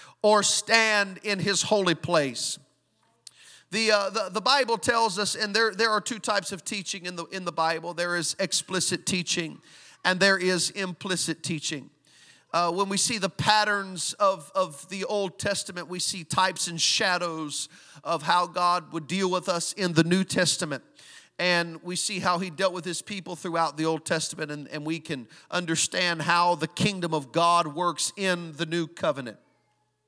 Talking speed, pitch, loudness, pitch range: 180 wpm, 180 Hz, -26 LUFS, 165-195 Hz